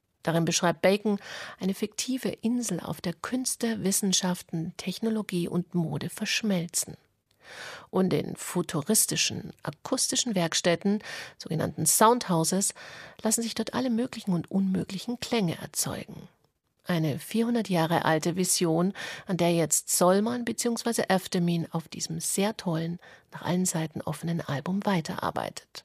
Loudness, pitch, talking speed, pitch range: -27 LUFS, 185 Hz, 120 wpm, 170-225 Hz